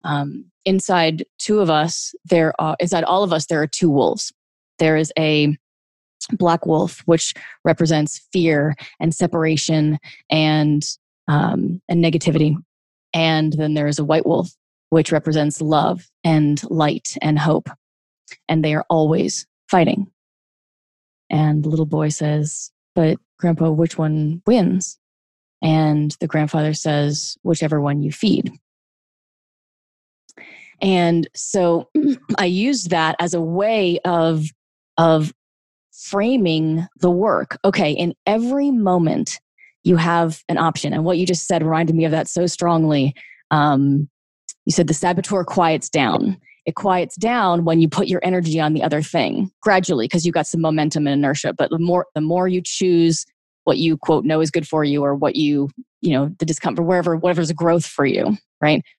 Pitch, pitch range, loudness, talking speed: 165 Hz, 155-180 Hz, -19 LUFS, 155 wpm